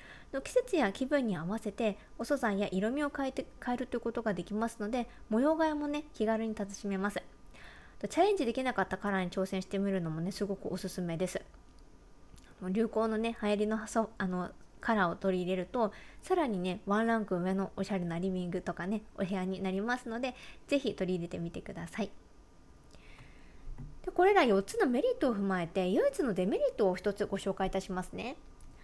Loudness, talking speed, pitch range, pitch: -33 LUFS, 380 characters per minute, 190-245 Hz, 210 Hz